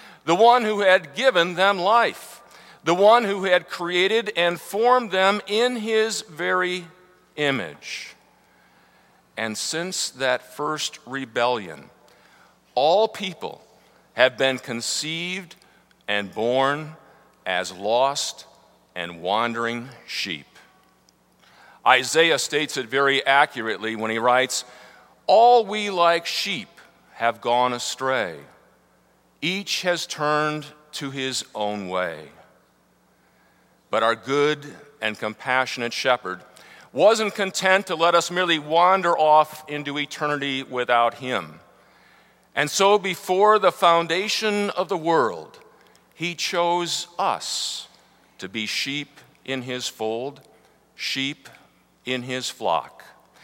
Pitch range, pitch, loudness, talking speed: 125-185 Hz, 150 Hz, -22 LUFS, 110 wpm